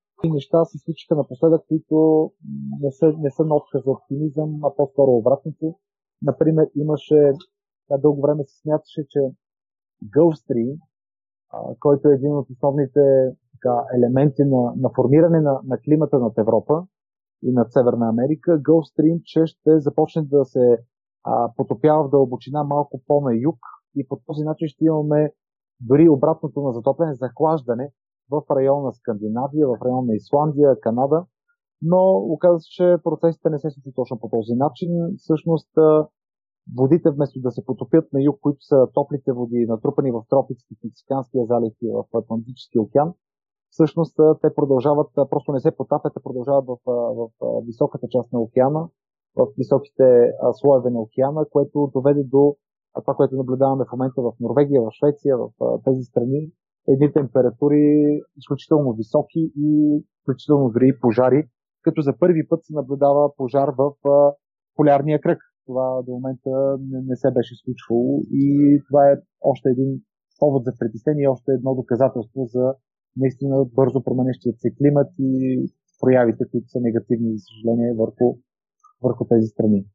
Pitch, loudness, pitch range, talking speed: 140 Hz, -20 LUFS, 125-155 Hz, 150 wpm